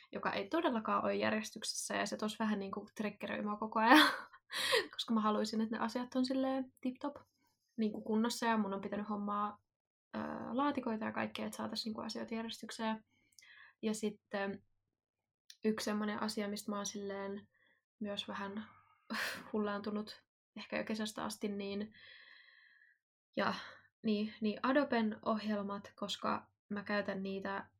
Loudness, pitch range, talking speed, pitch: -37 LUFS, 205-230 Hz, 135 wpm, 215 Hz